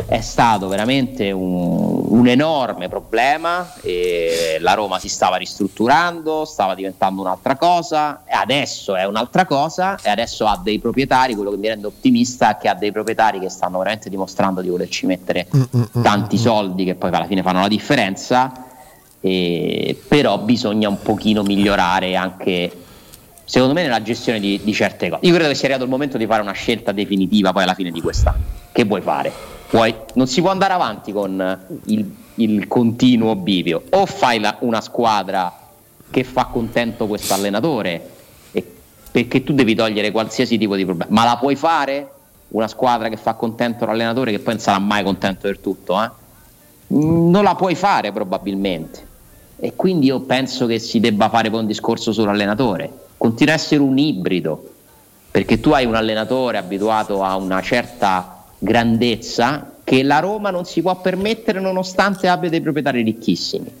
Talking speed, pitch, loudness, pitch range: 170 wpm, 115 Hz, -18 LUFS, 100-140 Hz